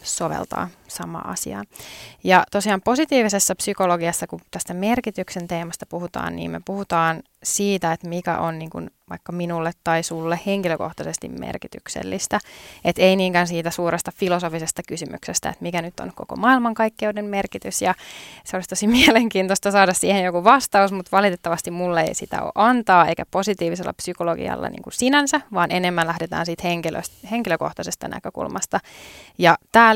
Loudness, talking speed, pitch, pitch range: -21 LUFS, 145 wpm, 180 Hz, 170-200 Hz